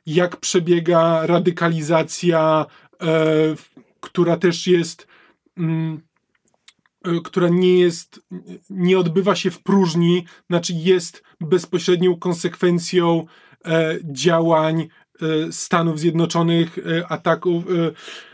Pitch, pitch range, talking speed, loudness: 170 Hz, 165-180 Hz, 70 wpm, -19 LUFS